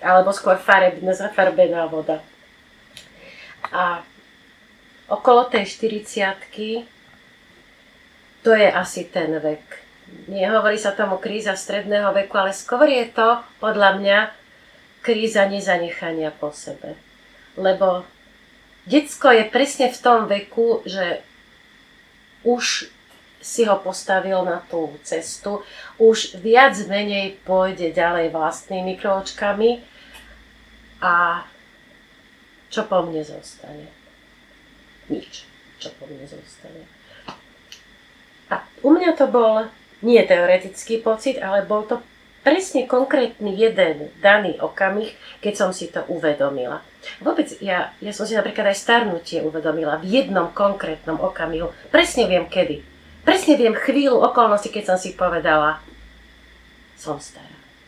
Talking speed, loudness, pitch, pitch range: 110 wpm, -19 LUFS, 200 Hz, 180-235 Hz